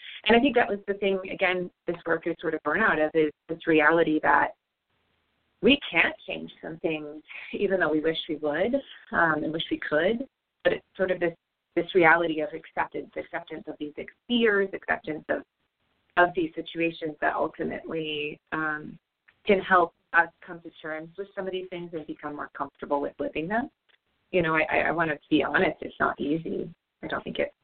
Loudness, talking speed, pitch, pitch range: -26 LUFS, 195 wpm, 165 Hz, 155-190 Hz